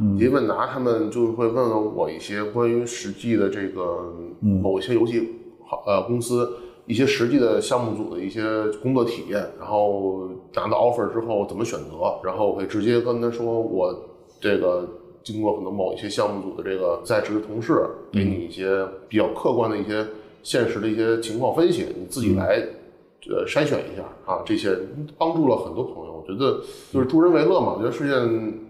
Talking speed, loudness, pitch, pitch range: 300 characters per minute, -23 LUFS, 115 Hz, 105-125 Hz